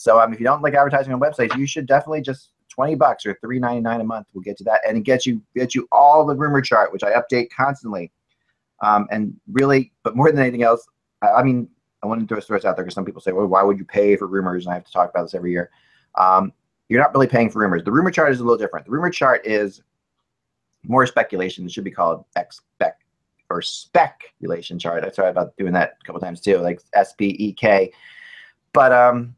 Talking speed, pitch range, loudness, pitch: 240 wpm, 100-135 Hz, -19 LUFS, 115 Hz